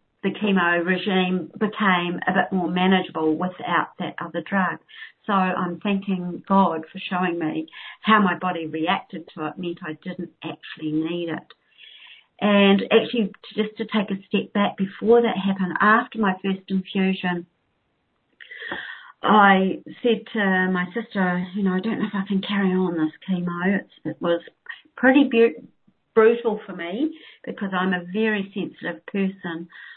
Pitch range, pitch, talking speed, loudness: 175-210 Hz, 190 Hz, 150 wpm, -22 LUFS